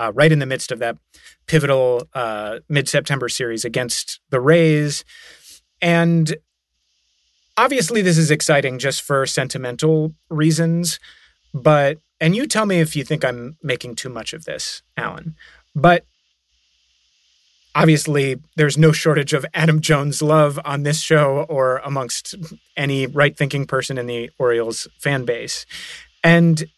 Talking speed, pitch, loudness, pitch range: 140 wpm, 145 Hz, -18 LUFS, 130-160 Hz